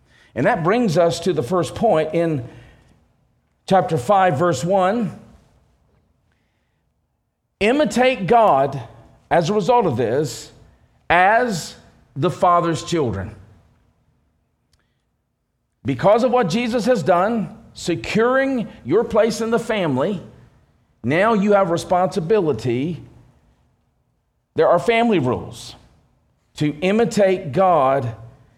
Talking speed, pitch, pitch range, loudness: 100 wpm, 180 Hz, 145-220 Hz, -18 LUFS